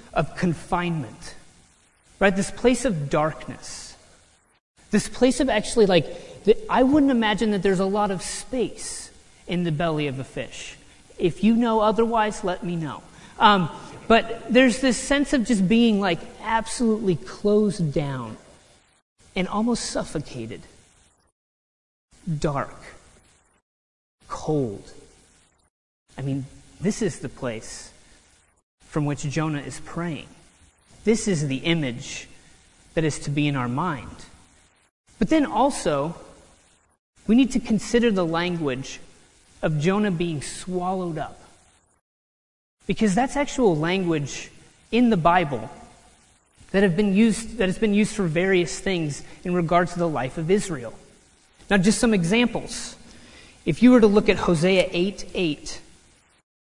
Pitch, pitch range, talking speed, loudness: 175 Hz, 130-215 Hz, 135 wpm, -23 LUFS